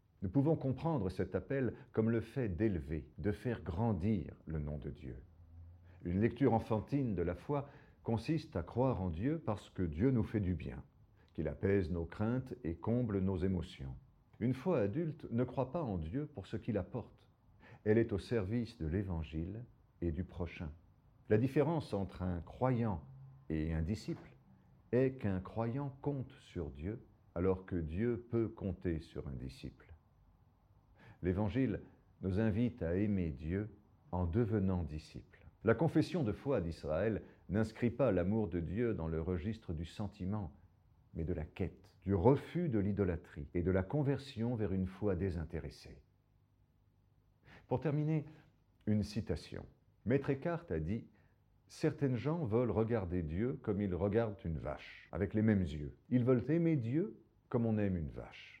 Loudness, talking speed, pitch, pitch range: -37 LUFS, 160 wpm, 105 Hz, 90-120 Hz